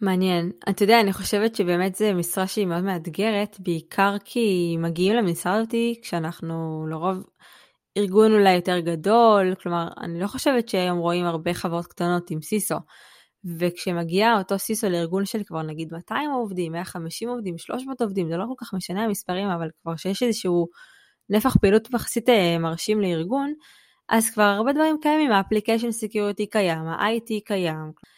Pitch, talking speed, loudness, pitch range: 195 Hz, 150 wpm, -23 LUFS, 175-220 Hz